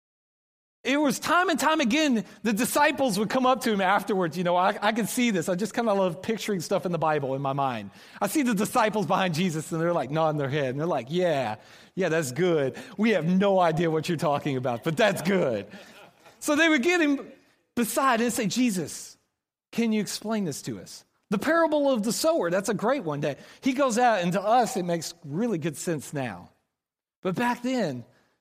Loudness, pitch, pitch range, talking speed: -25 LUFS, 200 Hz, 165-245 Hz, 220 wpm